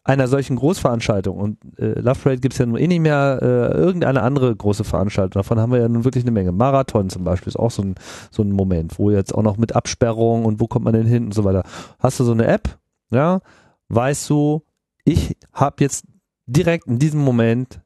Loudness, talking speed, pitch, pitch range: -19 LUFS, 225 wpm, 115 Hz, 105-135 Hz